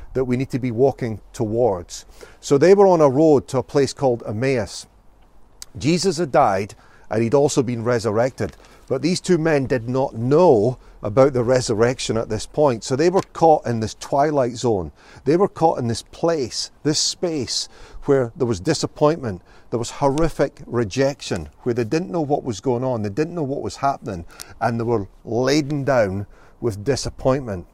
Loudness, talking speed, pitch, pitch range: -20 LUFS, 180 wpm, 130 Hz, 115-145 Hz